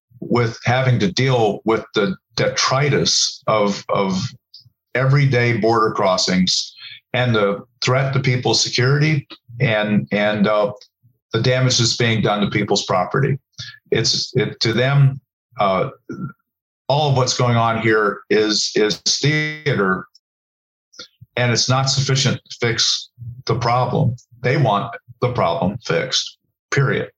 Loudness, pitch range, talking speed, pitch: -18 LUFS, 115-130 Hz, 125 wpm, 120 Hz